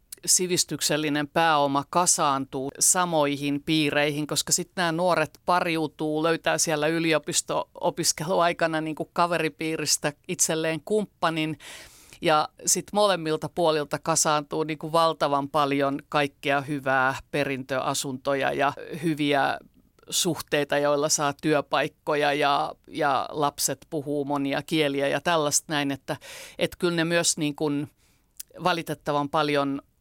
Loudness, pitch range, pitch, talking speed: -25 LUFS, 145-165 Hz, 155 Hz, 100 wpm